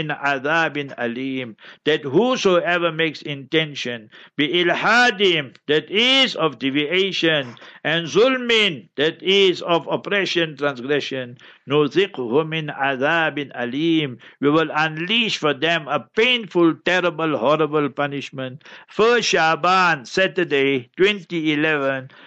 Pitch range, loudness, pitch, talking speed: 140-180 Hz, -19 LUFS, 160 Hz, 90 wpm